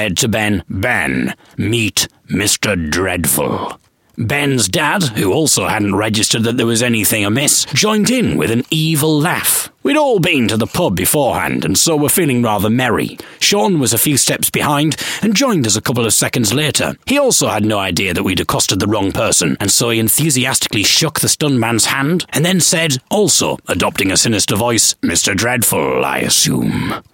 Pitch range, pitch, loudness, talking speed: 110-155 Hz, 125 Hz, -13 LUFS, 185 wpm